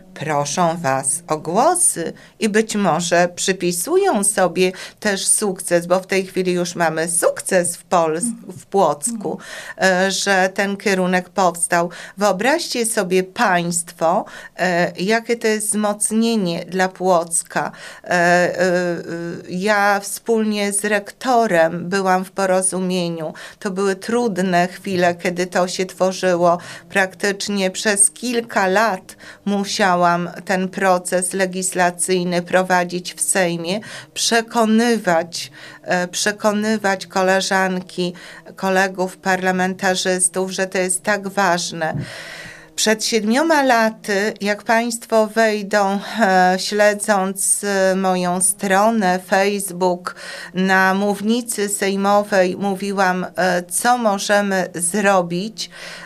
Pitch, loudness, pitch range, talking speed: 190 Hz, -18 LUFS, 180-205 Hz, 95 wpm